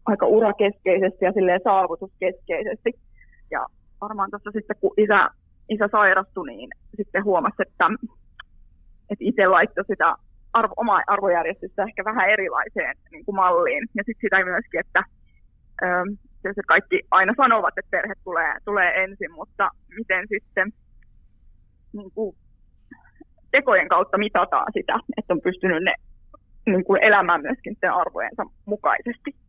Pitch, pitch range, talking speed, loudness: 200 Hz, 185-215 Hz, 130 wpm, -21 LUFS